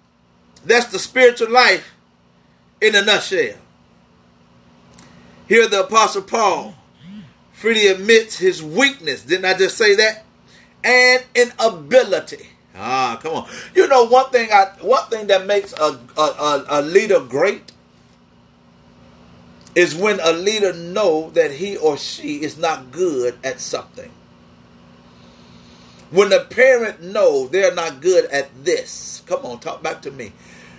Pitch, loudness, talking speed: 185 Hz, -16 LUFS, 135 wpm